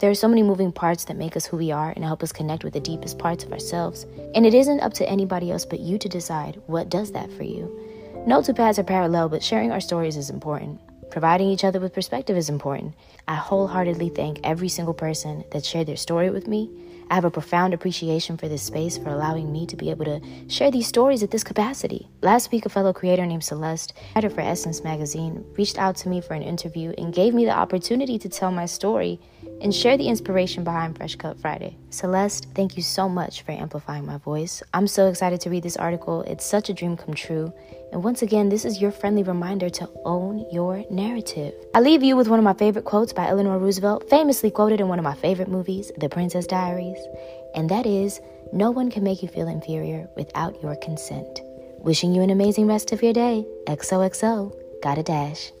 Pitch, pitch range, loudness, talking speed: 180 Hz, 160-200 Hz, -23 LUFS, 220 wpm